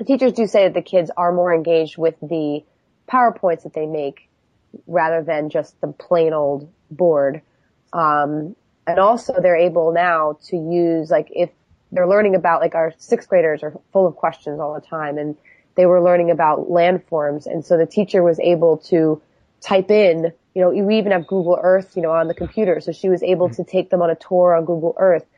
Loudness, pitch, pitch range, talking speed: -18 LUFS, 170 Hz, 160-180 Hz, 205 wpm